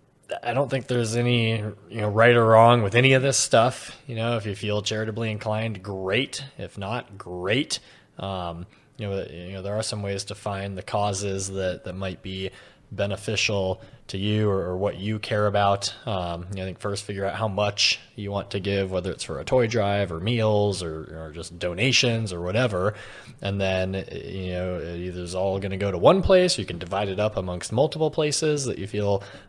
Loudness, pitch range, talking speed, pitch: -24 LUFS, 95-115 Hz, 215 wpm, 100 Hz